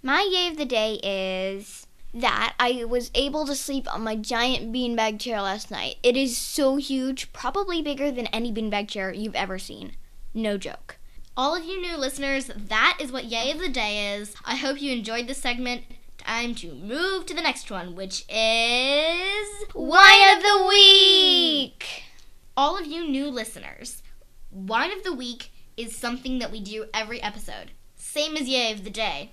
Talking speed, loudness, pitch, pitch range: 180 wpm, -21 LUFS, 250 Hz, 220-295 Hz